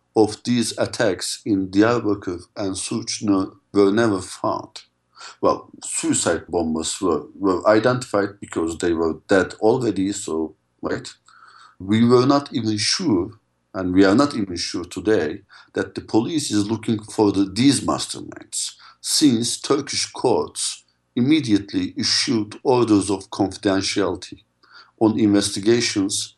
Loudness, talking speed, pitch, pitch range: -21 LUFS, 125 wpm, 100 Hz, 95-110 Hz